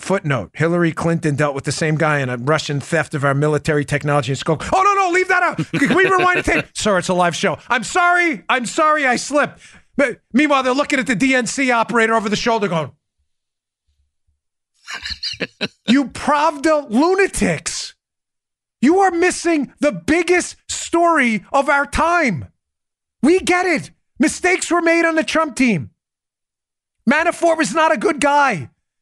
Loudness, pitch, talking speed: -17 LUFS, 255 Hz, 165 wpm